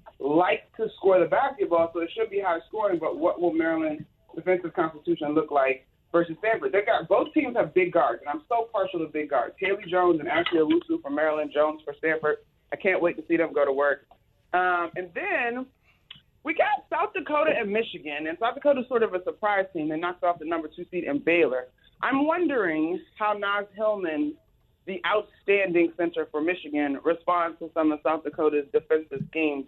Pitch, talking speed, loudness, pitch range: 175 Hz, 200 wpm, -26 LUFS, 155-230 Hz